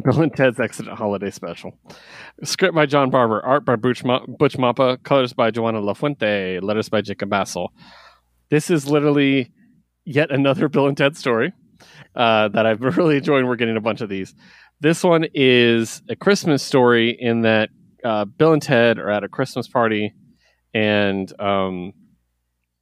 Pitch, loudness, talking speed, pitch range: 125 Hz, -19 LUFS, 170 wpm, 105-145 Hz